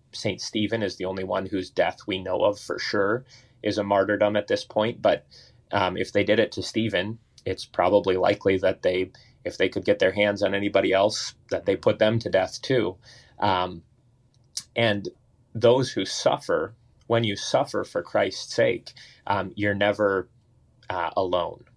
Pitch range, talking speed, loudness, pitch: 95-115 Hz, 175 wpm, -25 LUFS, 105 Hz